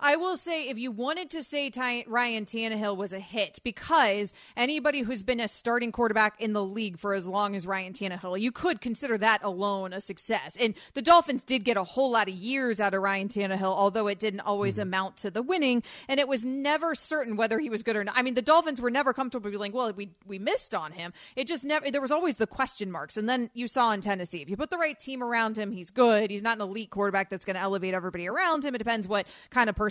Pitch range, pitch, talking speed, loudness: 200-260 Hz, 225 Hz, 255 wpm, -28 LUFS